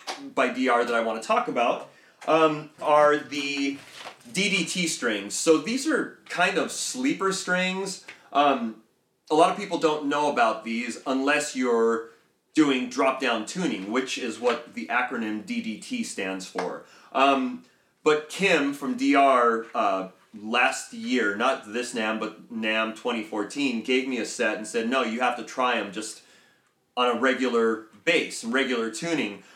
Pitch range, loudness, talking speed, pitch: 115-155 Hz, -25 LUFS, 155 wpm, 135 Hz